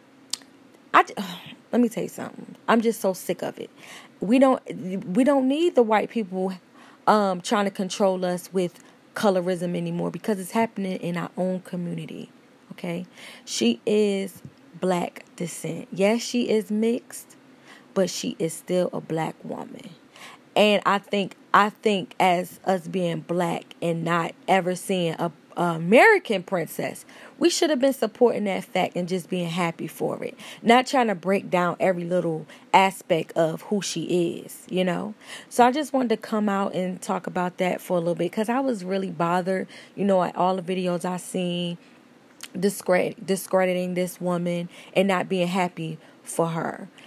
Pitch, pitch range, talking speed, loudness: 190 Hz, 180-235 Hz, 170 wpm, -24 LUFS